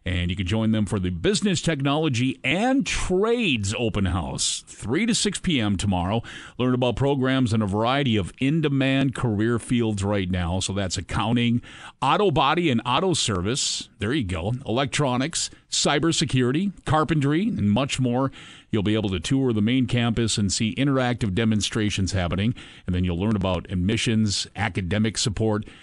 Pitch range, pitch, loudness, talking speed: 105-135 Hz, 115 Hz, -23 LUFS, 160 wpm